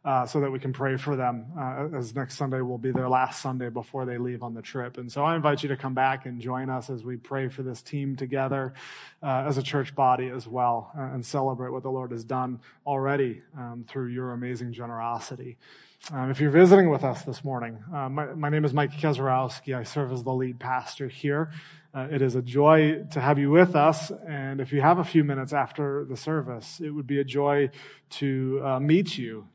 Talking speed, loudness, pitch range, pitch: 230 wpm, -27 LUFS, 125-145 Hz, 135 Hz